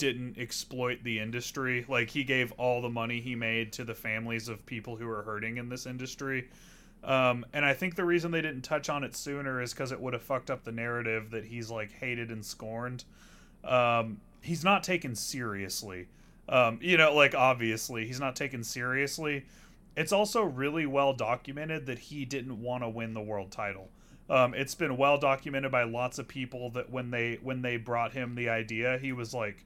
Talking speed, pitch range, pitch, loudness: 200 wpm, 115-135 Hz, 125 Hz, -31 LUFS